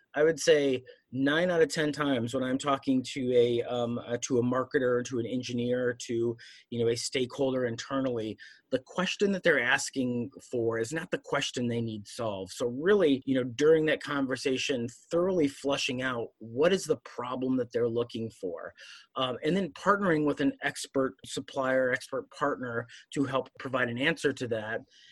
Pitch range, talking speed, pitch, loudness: 120-140 Hz, 180 wpm, 130 Hz, -30 LUFS